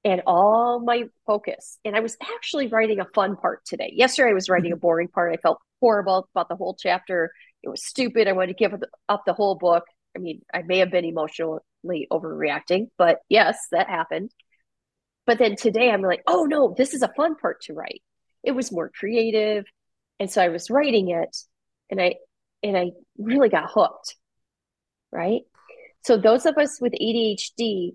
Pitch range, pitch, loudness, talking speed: 180-240 Hz, 210 Hz, -22 LUFS, 190 wpm